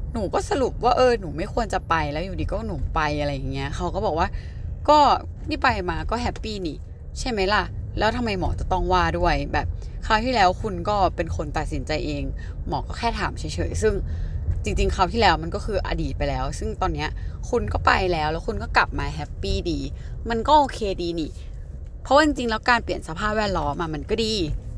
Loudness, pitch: -24 LUFS, 150 Hz